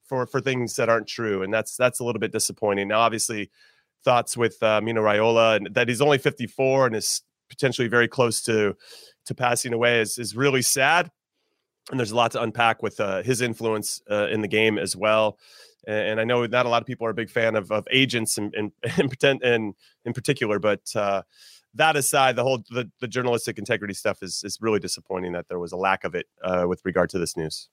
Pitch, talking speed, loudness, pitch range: 115 Hz, 225 wpm, -23 LUFS, 105-125 Hz